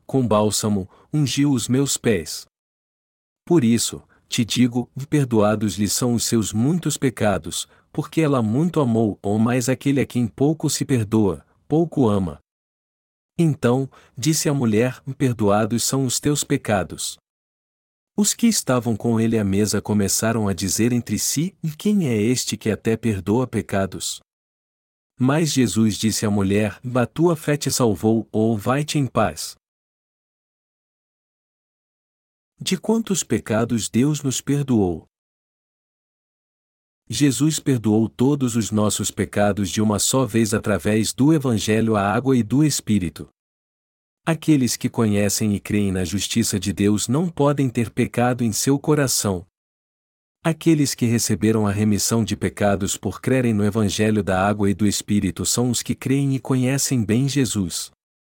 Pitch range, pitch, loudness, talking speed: 105-135 Hz, 115 Hz, -20 LUFS, 140 wpm